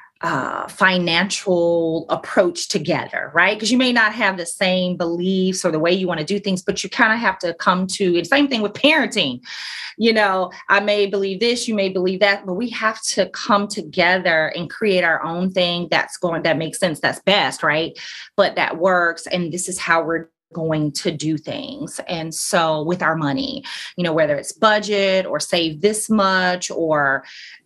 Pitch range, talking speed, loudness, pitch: 170-205 Hz, 195 wpm, -19 LUFS, 185 Hz